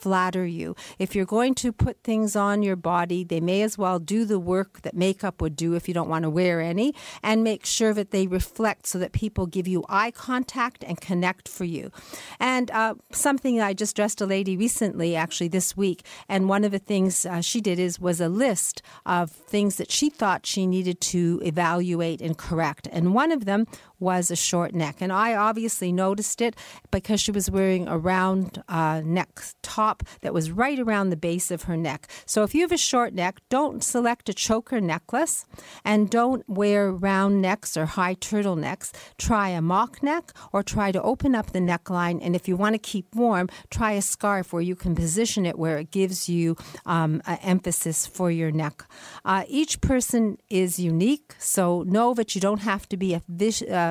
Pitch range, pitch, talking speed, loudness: 175-215 Hz, 190 Hz, 205 wpm, -25 LUFS